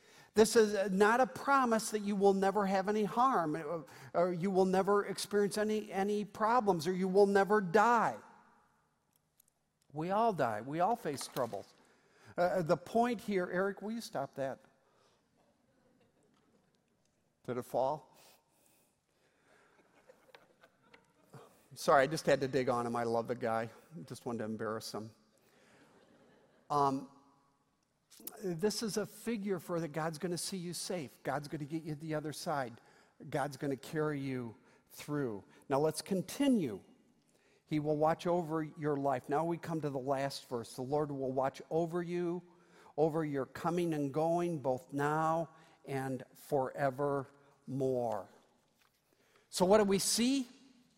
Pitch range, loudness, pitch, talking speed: 140-195 Hz, -34 LUFS, 165 Hz, 145 wpm